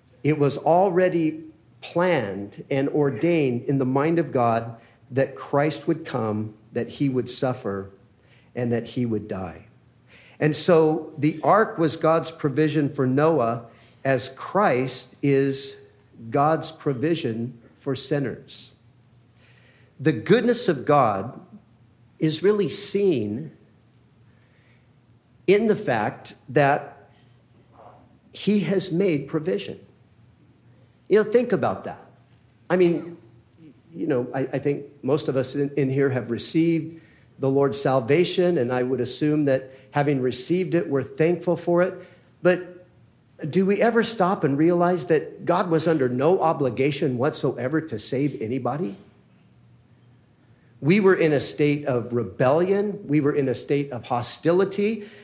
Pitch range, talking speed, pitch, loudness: 120-165 Hz, 130 wpm, 140 Hz, -23 LUFS